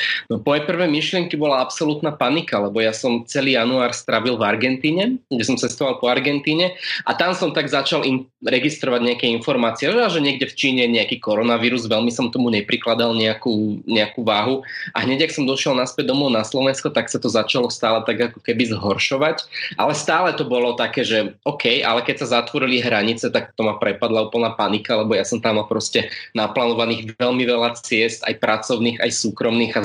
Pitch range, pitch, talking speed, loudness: 115-145 Hz, 125 Hz, 185 wpm, -19 LUFS